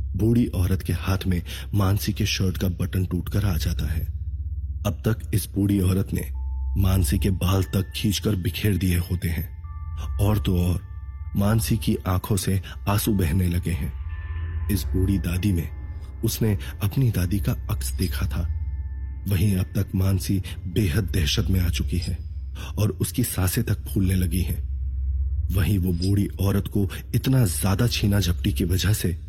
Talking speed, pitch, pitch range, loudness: 165 wpm, 95 Hz, 85-100 Hz, -25 LUFS